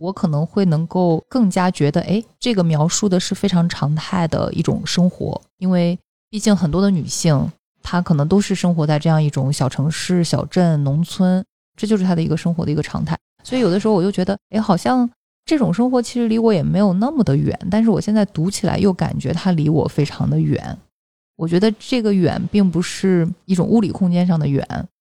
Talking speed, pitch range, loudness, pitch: 315 characters per minute, 165-205 Hz, -18 LUFS, 180 Hz